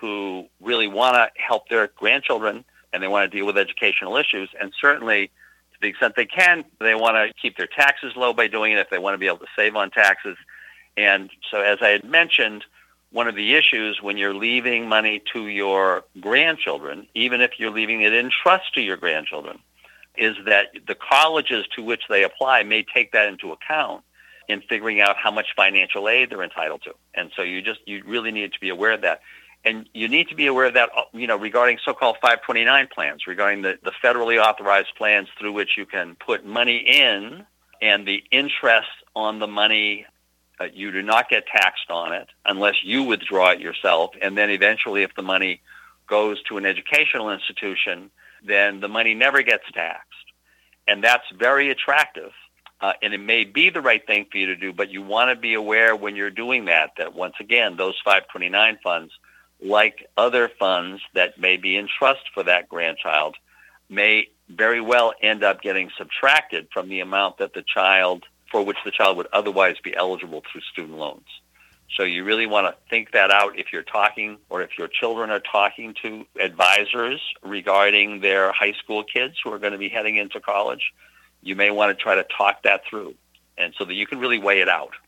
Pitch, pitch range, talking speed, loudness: 105 Hz, 100-115 Hz, 200 wpm, -19 LUFS